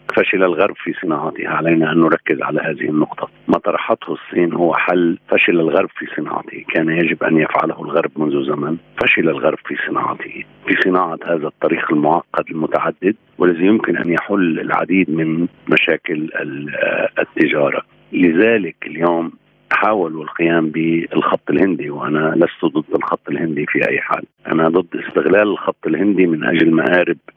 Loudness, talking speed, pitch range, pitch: -17 LUFS, 145 wpm, 80-85 Hz, 85 Hz